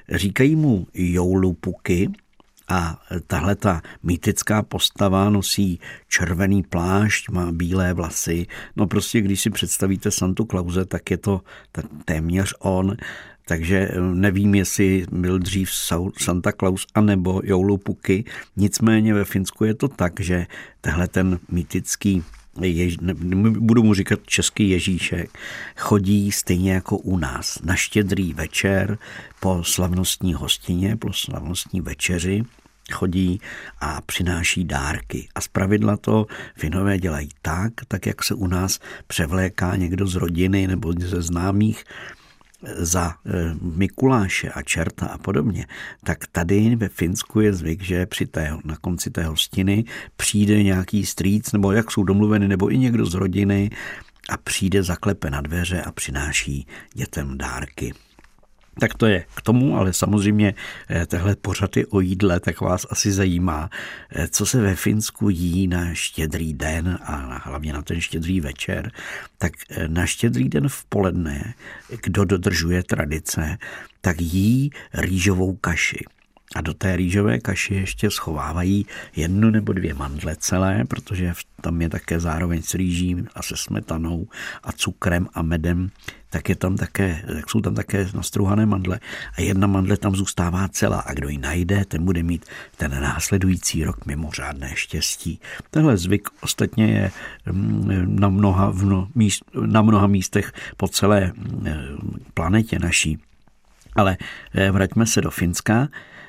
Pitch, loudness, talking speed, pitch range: 95 Hz, -21 LUFS, 140 wpm, 85-100 Hz